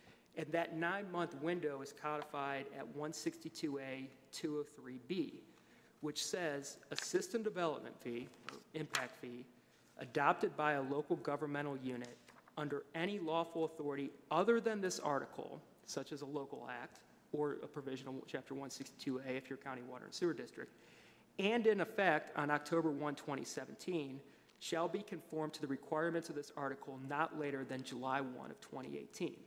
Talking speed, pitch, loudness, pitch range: 145 wpm, 150 Hz, -41 LUFS, 135-165 Hz